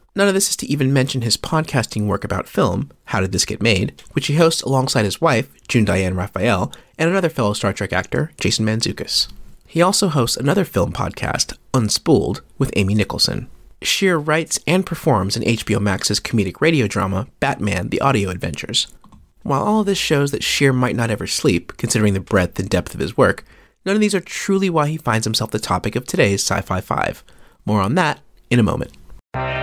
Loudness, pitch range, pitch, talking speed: -19 LUFS, 100-155 Hz, 115 Hz, 200 wpm